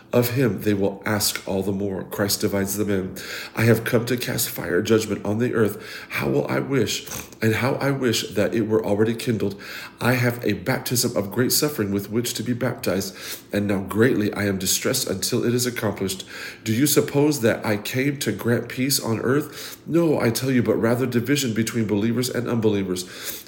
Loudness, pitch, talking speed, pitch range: -22 LUFS, 115 Hz, 200 wpm, 105-125 Hz